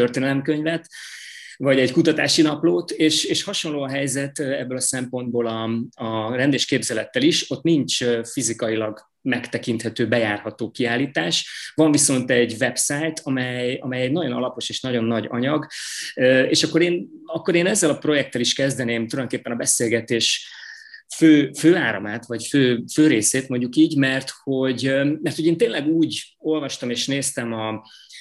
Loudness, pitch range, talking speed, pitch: -21 LUFS, 120-155 Hz, 145 wpm, 130 Hz